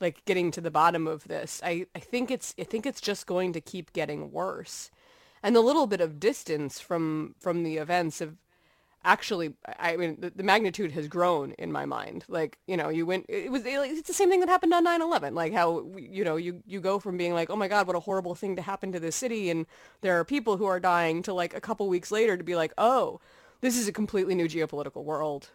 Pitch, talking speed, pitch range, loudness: 180 Hz, 240 wpm, 170-210 Hz, -28 LUFS